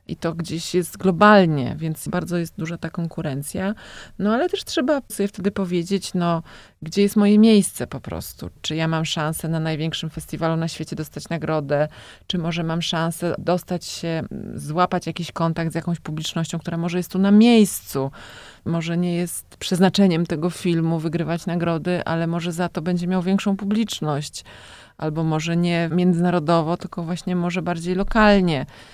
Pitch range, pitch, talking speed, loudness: 160-185 Hz, 170 Hz, 165 wpm, -22 LUFS